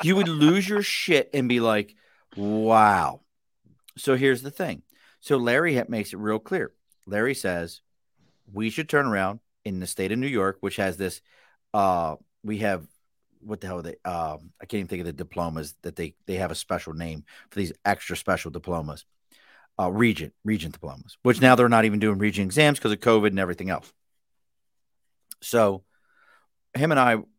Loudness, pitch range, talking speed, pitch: -24 LUFS, 90-120 Hz, 185 wpm, 105 Hz